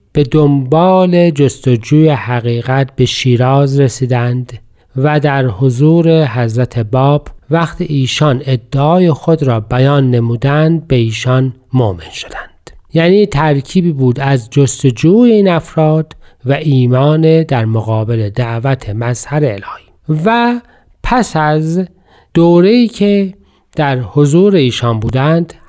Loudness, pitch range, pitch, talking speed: -11 LUFS, 125-160 Hz, 140 Hz, 105 wpm